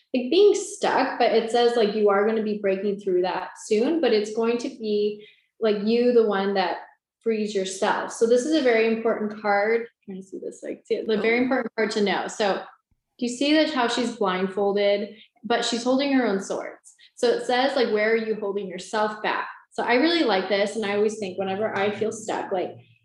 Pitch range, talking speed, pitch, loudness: 205-245 Hz, 220 wpm, 220 Hz, -23 LUFS